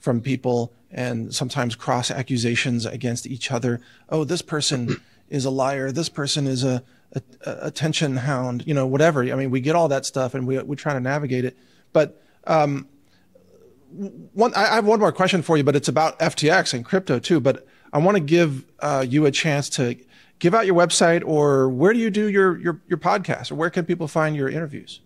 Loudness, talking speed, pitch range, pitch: -21 LUFS, 210 wpm, 130-165 Hz, 145 Hz